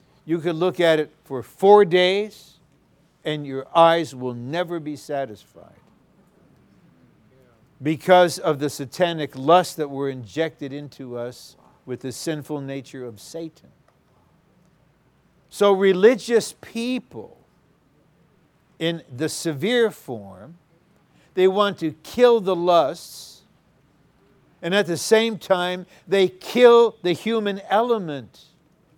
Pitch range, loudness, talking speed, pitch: 145-190 Hz, -21 LUFS, 110 wpm, 165 Hz